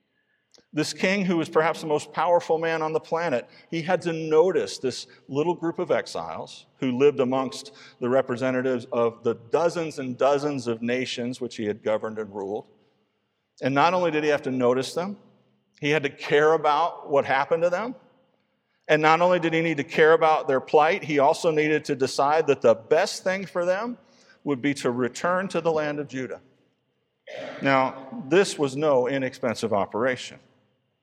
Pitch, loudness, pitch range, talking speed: 150 Hz, -24 LUFS, 130-170 Hz, 180 wpm